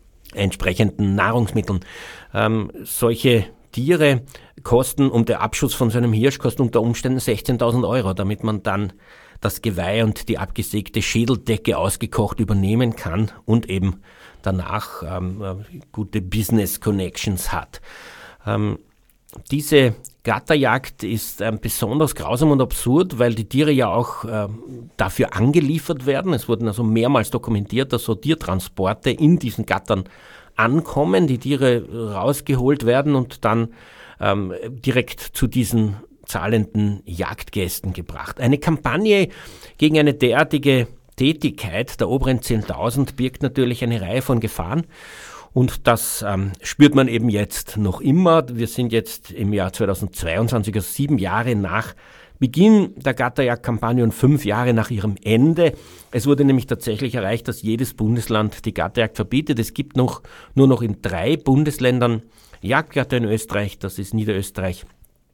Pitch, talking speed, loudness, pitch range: 115 Hz, 135 wpm, -20 LUFS, 105-130 Hz